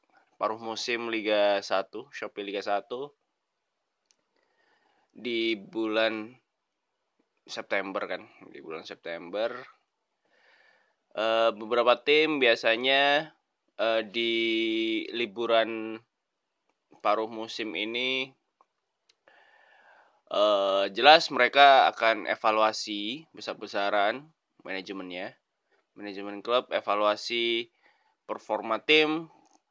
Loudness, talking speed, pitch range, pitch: -26 LUFS, 65 wpm, 110-135 Hz, 115 Hz